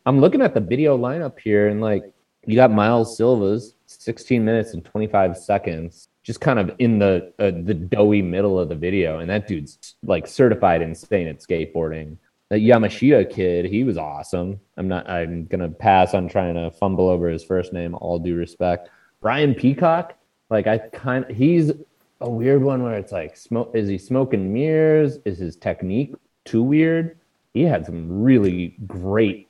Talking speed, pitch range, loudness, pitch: 175 wpm, 90-120 Hz, -20 LUFS, 100 Hz